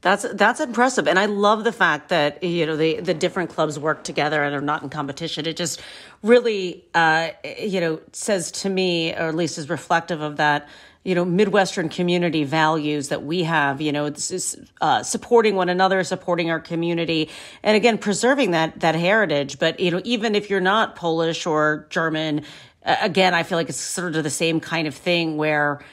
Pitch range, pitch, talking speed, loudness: 155-190 Hz, 170 Hz, 200 wpm, -21 LUFS